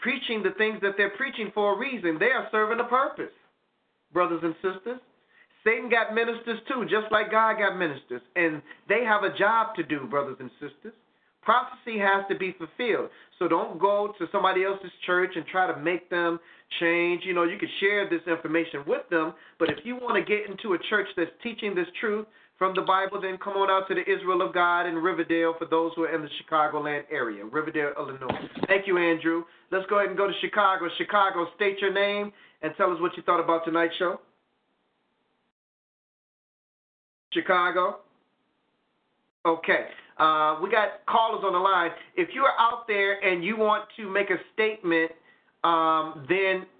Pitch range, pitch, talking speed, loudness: 170-215 Hz, 190 Hz, 185 wpm, -26 LUFS